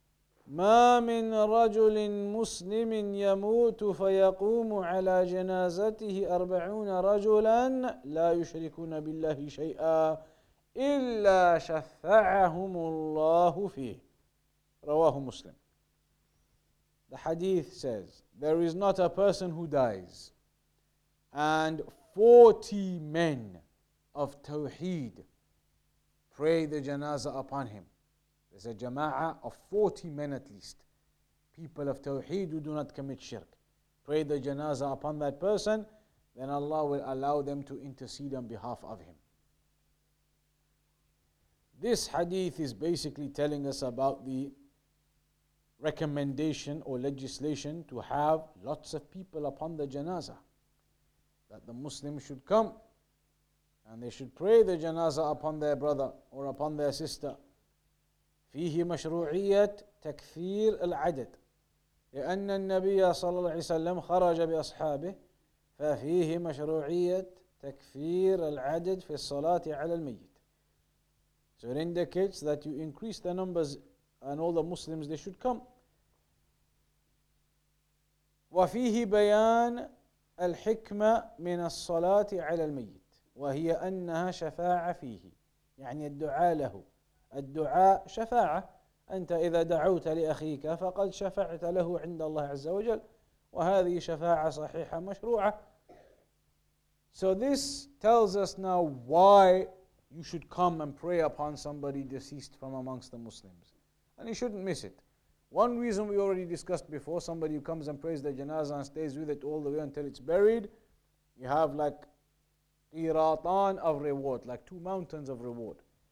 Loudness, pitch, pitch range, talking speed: -31 LUFS, 160 Hz, 145-185 Hz, 120 wpm